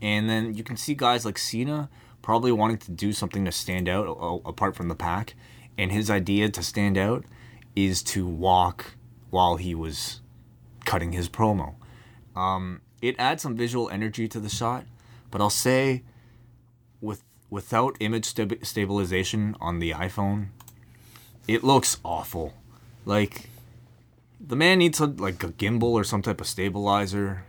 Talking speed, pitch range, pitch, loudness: 155 wpm, 100-120 Hz, 110 Hz, -26 LUFS